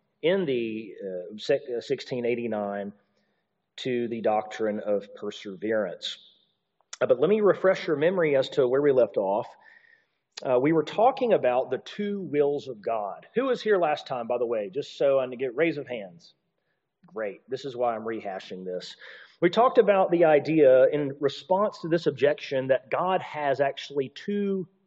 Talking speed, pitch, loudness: 165 wpm, 150 Hz, -26 LUFS